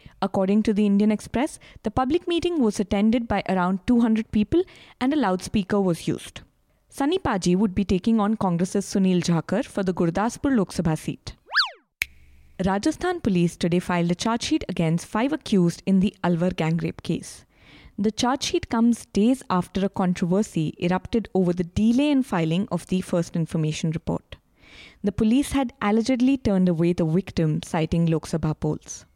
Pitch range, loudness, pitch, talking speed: 175-230 Hz, -23 LUFS, 195 Hz, 165 wpm